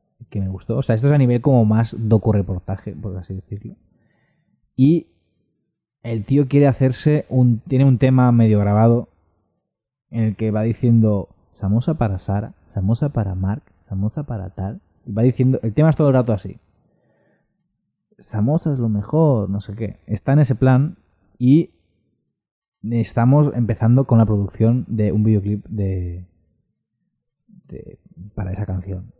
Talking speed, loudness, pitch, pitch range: 155 wpm, -18 LUFS, 115 Hz, 100-130 Hz